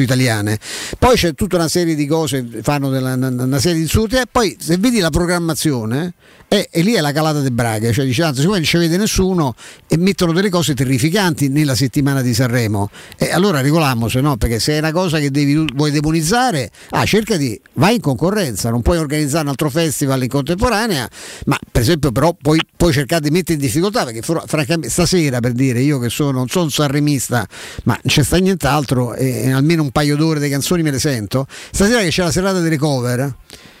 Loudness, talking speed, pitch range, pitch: -16 LUFS, 210 wpm, 130-170 Hz, 150 Hz